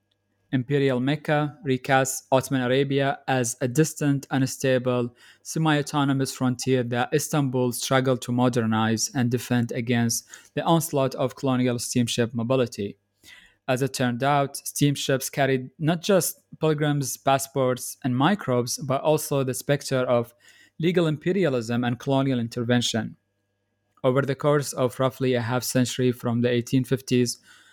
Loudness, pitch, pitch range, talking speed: -24 LUFS, 130 Hz, 125-140 Hz, 130 wpm